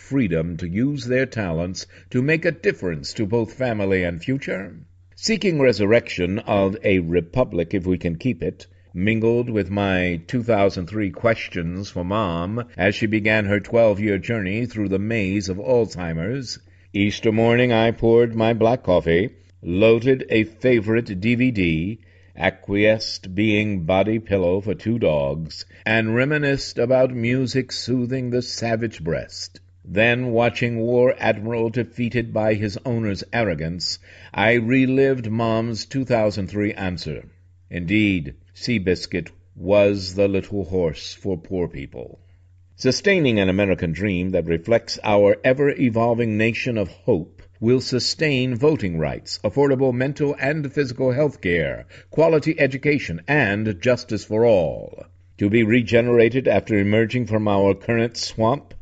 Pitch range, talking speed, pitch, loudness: 95-120 Hz, 135 wpm, 110 Hz, -21 LUFS